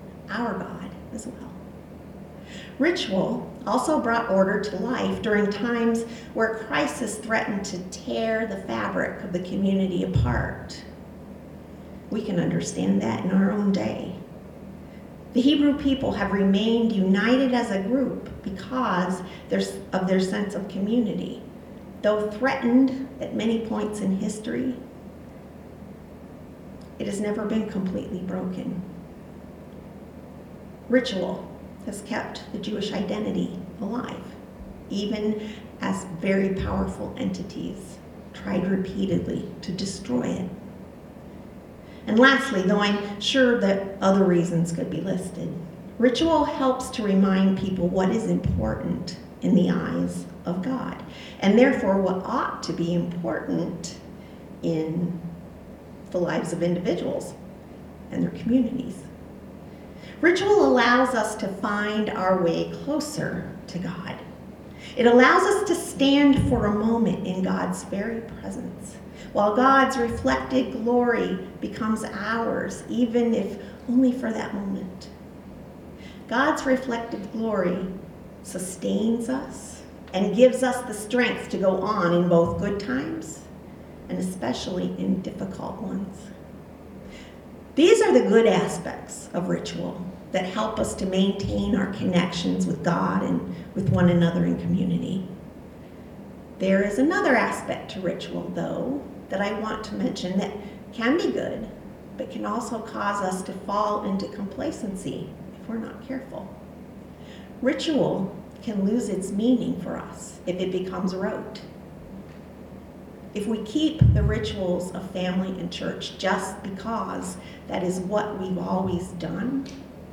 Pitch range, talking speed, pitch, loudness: 185-235 Hz, 125 wpm, 205 Hz, -25 LUFS